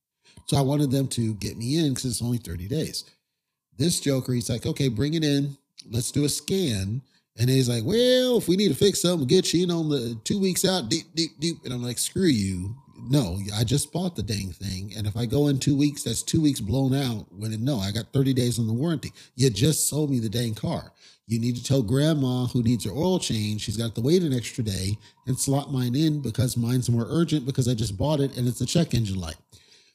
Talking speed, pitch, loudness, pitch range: 245 wpm, 130 Hz, -25 LUFS, 115-150 Hz